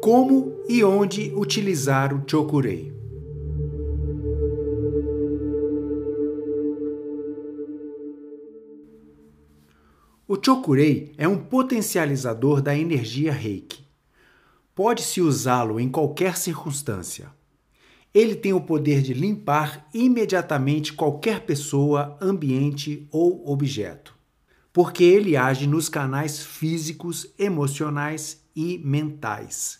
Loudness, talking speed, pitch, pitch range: -23 LUFS, 80 wpm, 150 Hz, 140-170 Hz